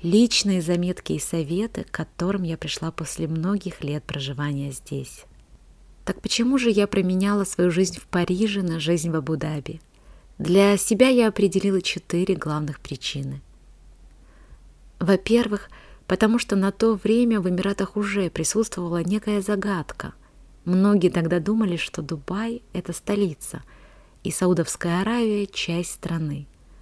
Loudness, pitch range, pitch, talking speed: -23 LUFS, 160-205 Hz, 180 Hz, 130 wpm